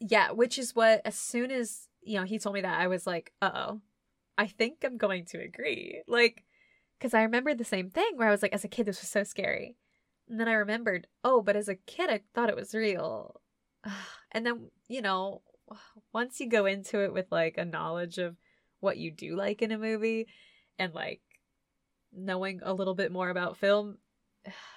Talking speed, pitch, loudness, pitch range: 210 wpm, 210 Hz, -31 LUFS, 195-235 Hz